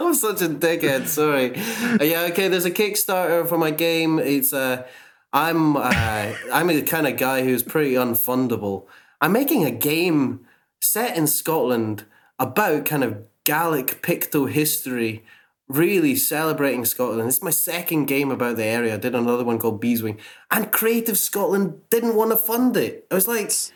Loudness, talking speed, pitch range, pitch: -21 LUFS, 165 wpm, 125-180 Hz, 150 Hz